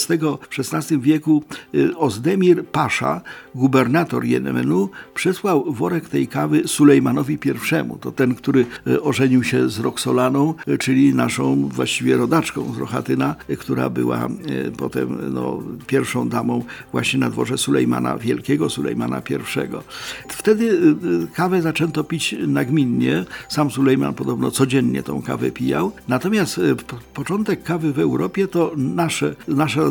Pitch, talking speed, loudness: 130 Hz, 120 wpm, -19 LUFS